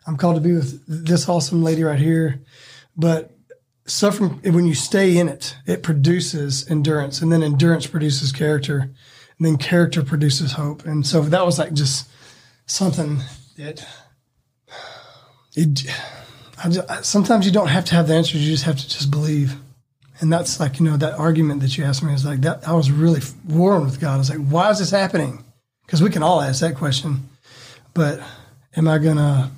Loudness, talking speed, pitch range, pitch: -19 LUFS, 190 wpm, 135-165 Hz, 155 Hz